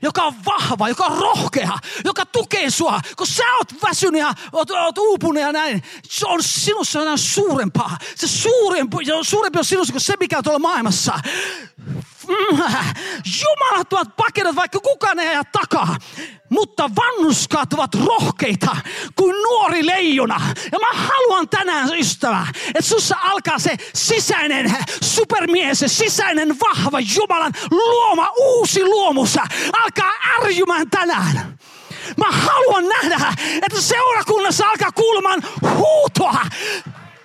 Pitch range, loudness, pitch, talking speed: 320-425 Hz, -17 LUFS, 380 Hz, 125 wpm